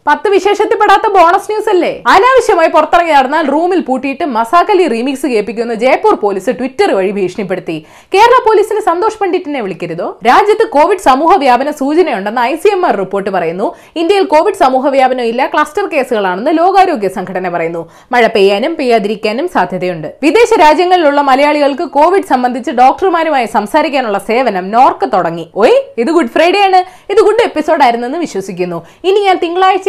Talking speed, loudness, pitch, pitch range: 145 wpm, -10 LUFS, 300 Hz, 230-375 Hz